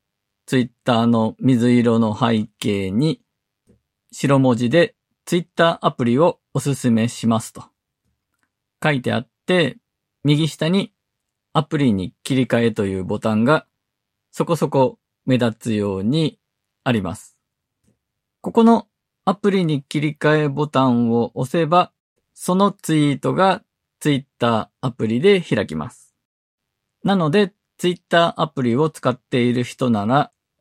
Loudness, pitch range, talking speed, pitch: -19 LUFS, 115-165 Hz, 255 characters per minute, 130 Hz